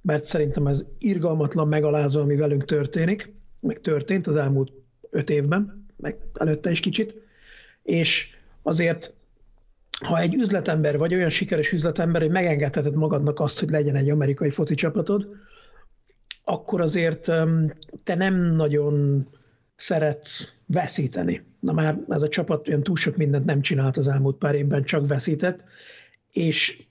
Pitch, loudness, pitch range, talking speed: 155 Hz, -23 LUFS, 145-175 Hz, 140 wpm